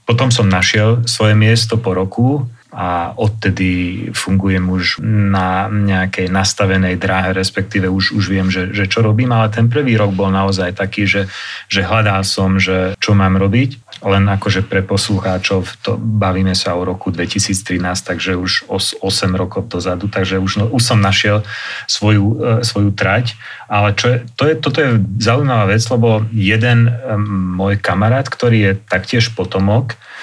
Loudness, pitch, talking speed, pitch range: -14 LUFS, 100 Hz, 155 wpm, 95-110 Hz